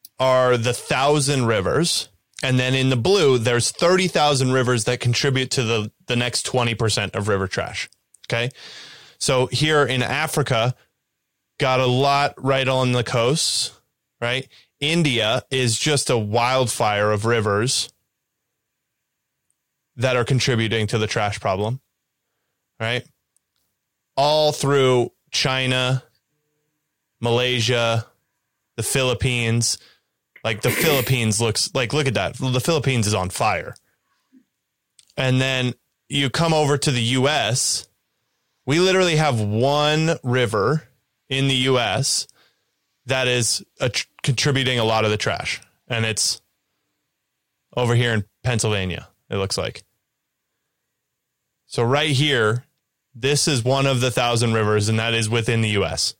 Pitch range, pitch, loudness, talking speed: 115-140 Hz, 125 Hz, -20 LUFS, 130 wpm